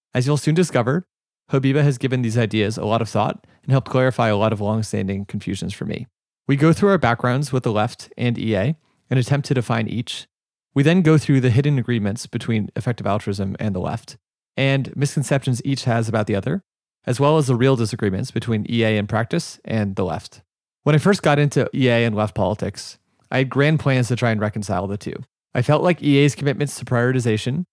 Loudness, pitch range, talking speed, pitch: -20 LUFS, 110-140 Hz, 210 wpm, 125 Hz